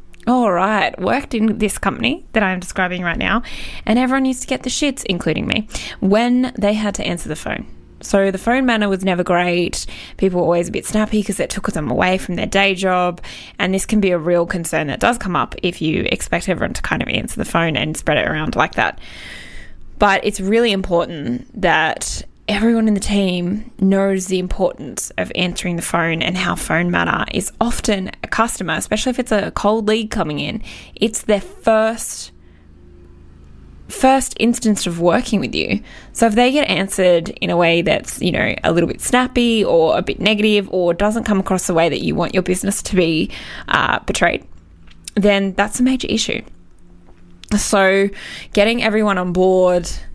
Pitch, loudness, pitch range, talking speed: 195 Hz, -17 LUFS, 175-220 Hz, 195 wpm